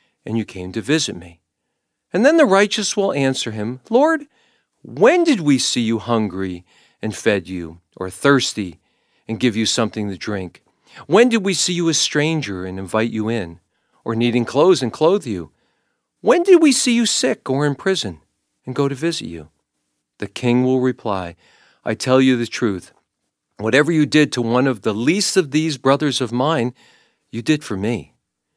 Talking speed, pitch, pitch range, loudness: 185 wpm, 120 Hz, 100-155 Hz, -18 LUFS